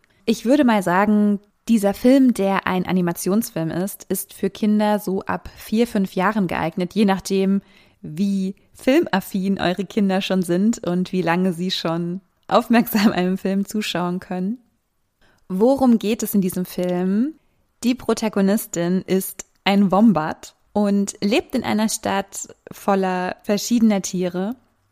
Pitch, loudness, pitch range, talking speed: 195 Hz, -20 LUFS, 185-220 Hz, 135 wpm